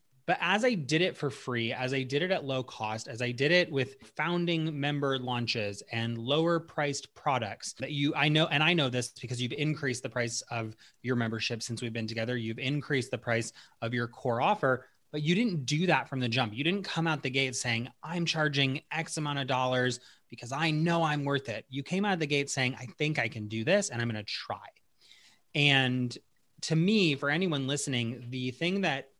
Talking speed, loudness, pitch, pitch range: 220 wpm, -30 LUFS, 135 Hz, 125-155 Hz